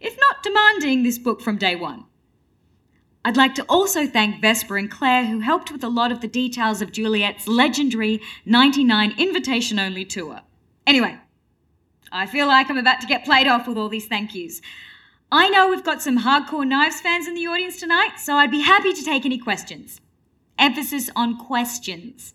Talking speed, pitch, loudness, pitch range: 185 wpm, 255 Hz, -19 LUFS, 220-295 Hz